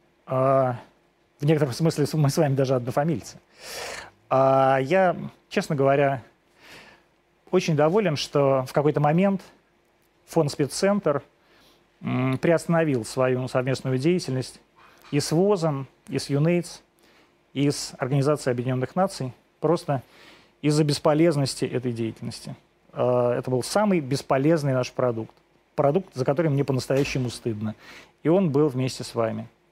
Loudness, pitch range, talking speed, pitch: -24 LUFS, 130-160 Hz, 115 wpm, 140 Hz